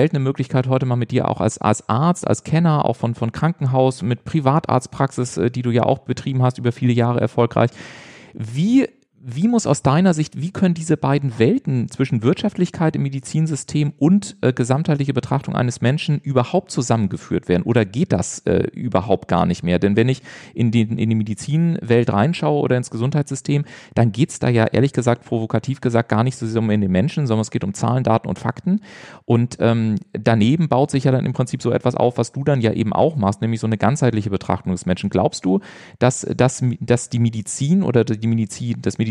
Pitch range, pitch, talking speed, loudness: 115-145 Hz, 125 Hz, 205 wpm, -19 LUFS